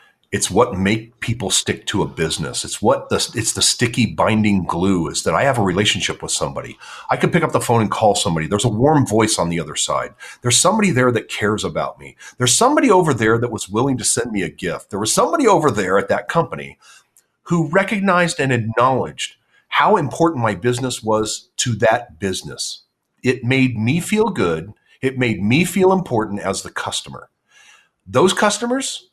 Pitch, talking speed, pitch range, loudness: 120 Hz, 195 wpm, 105-165 Hz, -18 LUFS